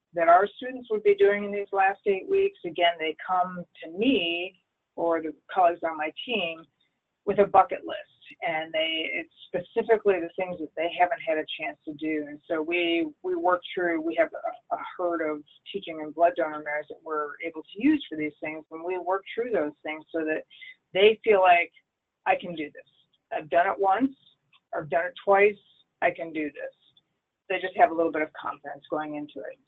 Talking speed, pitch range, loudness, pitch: 210 wpm, 155-205 Hz, -27 LUFS, 175 Hz